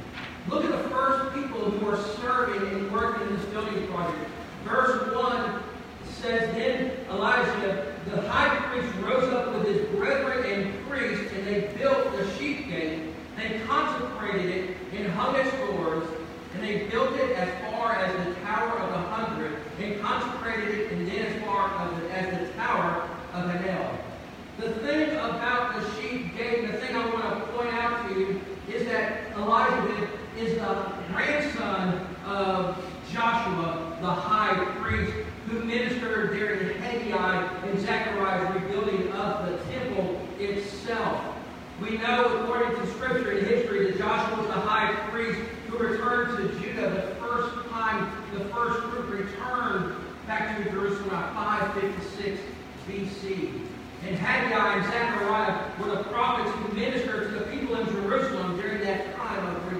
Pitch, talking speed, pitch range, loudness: 210 Hz, 155 wpm, 195-235 Hz, -28 LUFS